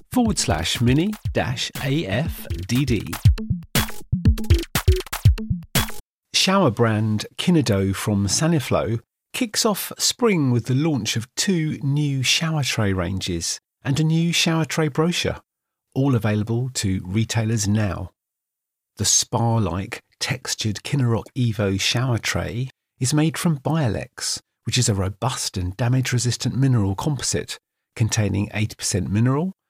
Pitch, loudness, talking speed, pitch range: 120 Hz, -22 LUFS, 115 wpm, 105-145 Hz